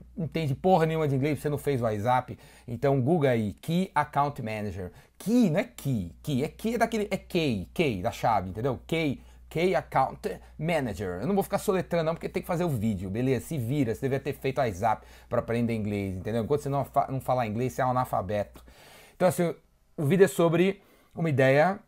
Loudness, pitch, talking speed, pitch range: -28 LUFS, 140 Hz, 215 wpm, 120-170 Hz